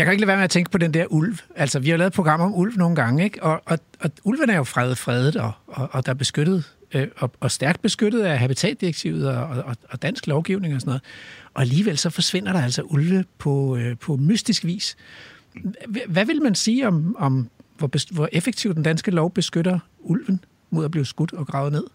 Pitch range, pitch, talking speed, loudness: 140-190 Hz, 165 Hz, 240 wpm, -22 LUFS